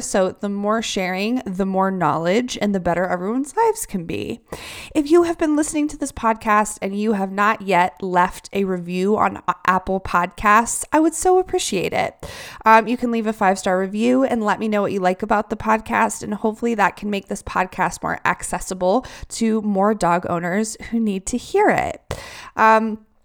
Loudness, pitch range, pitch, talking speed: -20 LUFS, 190-235 Hz, 215 Hz, 195 wpm